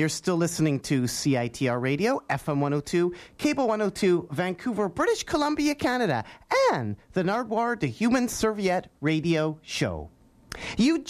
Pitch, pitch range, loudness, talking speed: 180 Hz, 150-235 Hz, -26 LUFS, 125 wpm